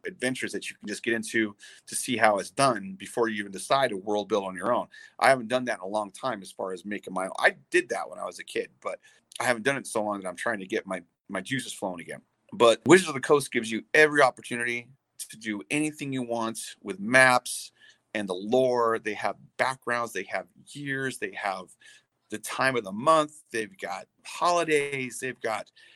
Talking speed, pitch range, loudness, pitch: 225 wpm, 110-140 Hz, -27 LUFS, 125 Hz